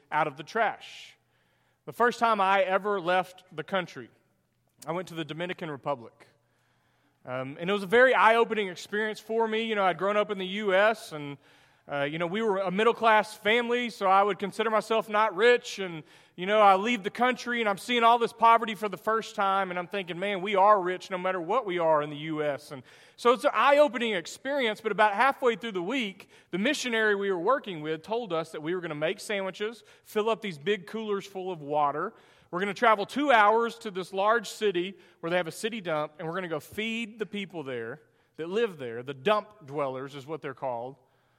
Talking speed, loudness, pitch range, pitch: 230 wpm, -27 LUFS, 170-220 Hz, 200 Hz